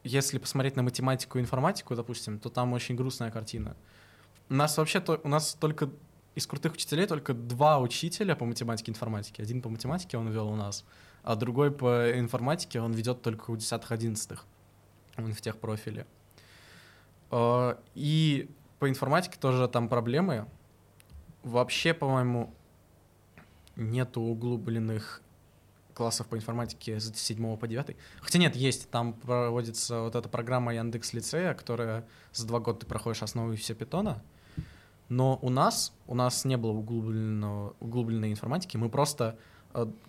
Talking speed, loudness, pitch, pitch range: 145 wpm, -31 LUFS, 120 Hz, 110-130 Hz